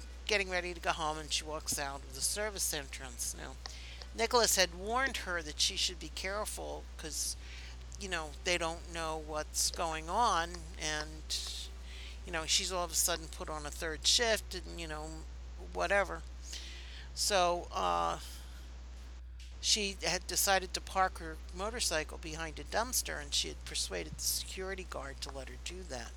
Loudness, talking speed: -34 LUFS, 165 wpm